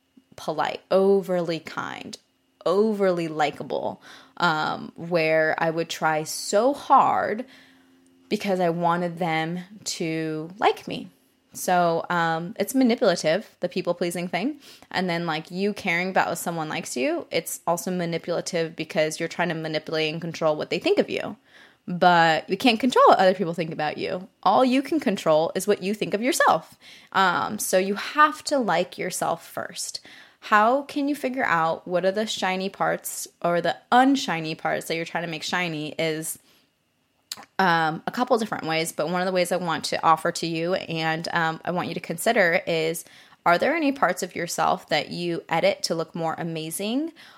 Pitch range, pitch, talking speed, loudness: 160-205 Hz, 175 Hz, 175 wpm, -24 LUFS